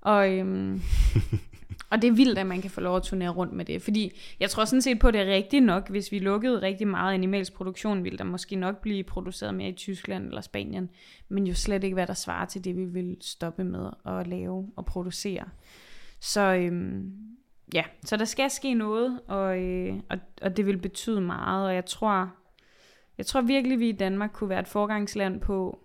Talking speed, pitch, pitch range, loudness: 215 wpm, 195 Hz, 185-210 Hz, -28 LUFS